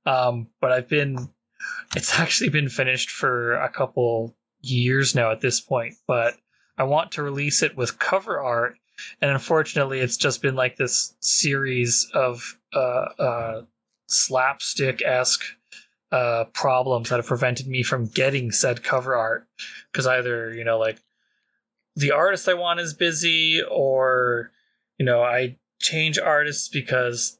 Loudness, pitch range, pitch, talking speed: -22 LUFS, 120-140 Hz, 130 Hz, 145 wpm